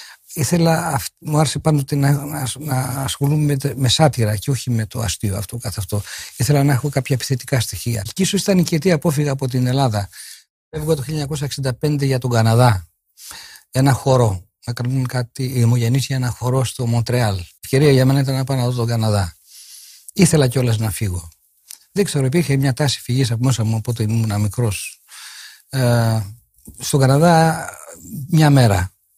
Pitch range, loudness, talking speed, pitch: 115-145 Hz, -18 LUFS, 170 wpm, 130 Hz